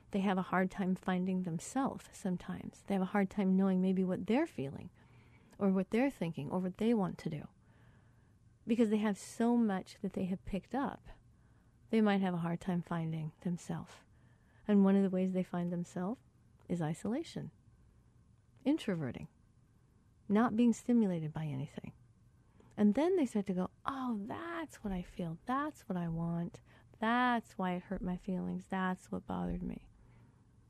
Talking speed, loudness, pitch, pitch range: 170 wpm, -36 LUFS, 190 Hz, 170-215 Hz